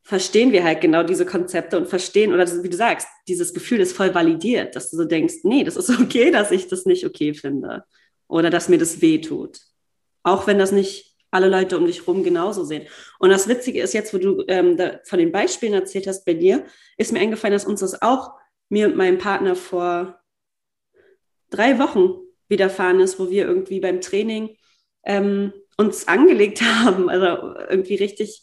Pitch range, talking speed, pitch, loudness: 185-245 Hz, 195 wpm, 200 Hz, -19 LUFS